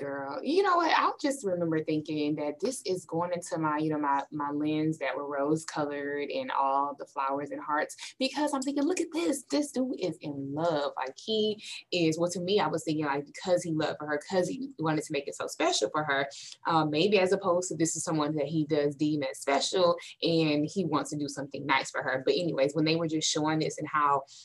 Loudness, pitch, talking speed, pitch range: -30 LUFS, 155 Hz, 245 wpm, 145-180 Hz